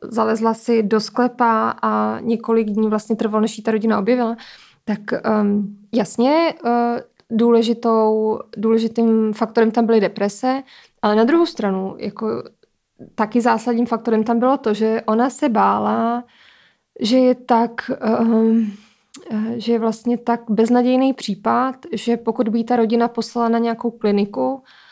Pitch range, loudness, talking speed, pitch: 220-235 Hz, -19 LUFS, 135 wpm, 225 Hz